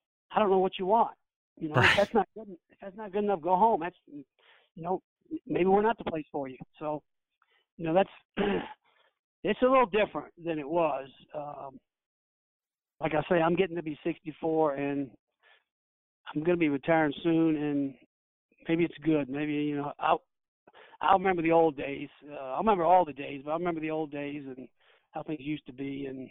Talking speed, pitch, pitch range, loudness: 200 wpm, 155 Hz, 145-180 Hz, -29 LUFS